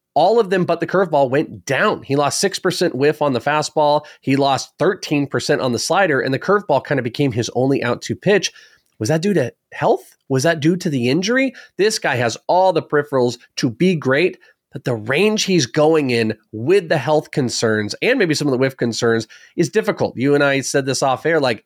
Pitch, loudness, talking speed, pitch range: 145 Hz, -18 LUFS, 220 wpm, 130-170 Hz